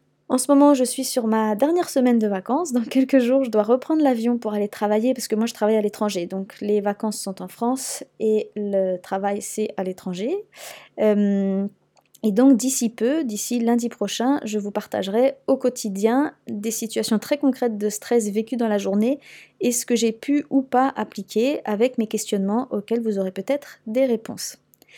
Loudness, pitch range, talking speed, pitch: -22 LUFS, 210-260 Hz, 190 wpm, 230 Hz